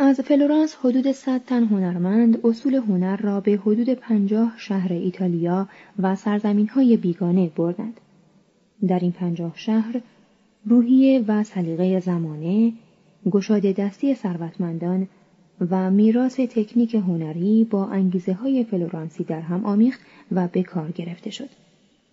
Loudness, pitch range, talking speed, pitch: -21 LUFS, 185-230 Hz, 125 wpm, 200 Hz